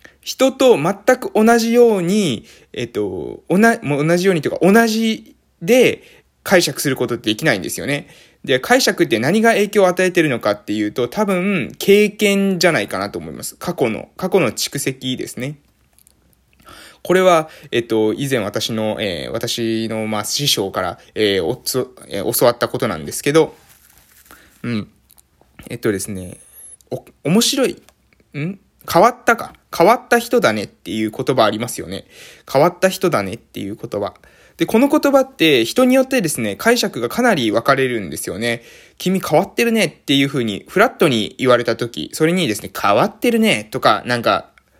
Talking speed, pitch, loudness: 335 characters per minute, 170 Hz, -17 LUFS